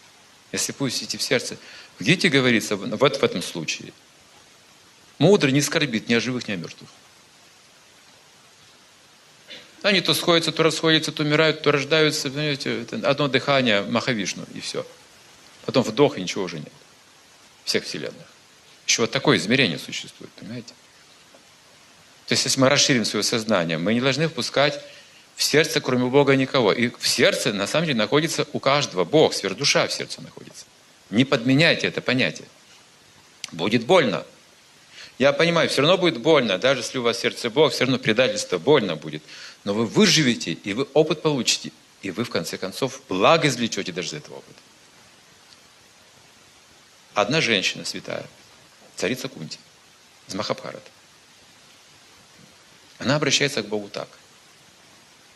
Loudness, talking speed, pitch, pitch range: -21 LUFS, 145 wpm, 140 Hz, 115-155 Hz